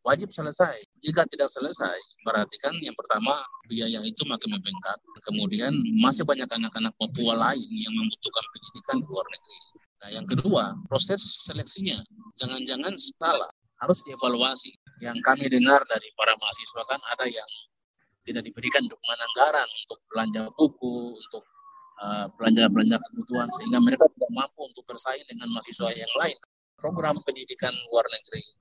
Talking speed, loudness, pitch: 140 wpm, -24 LUFS, 170 Hz